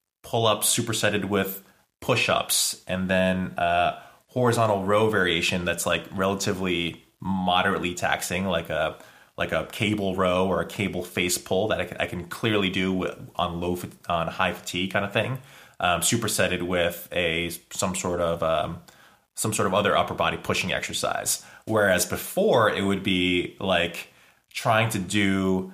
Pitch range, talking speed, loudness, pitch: 90-105 Hz, 155 wpm, -25 LUFS, 95 Hz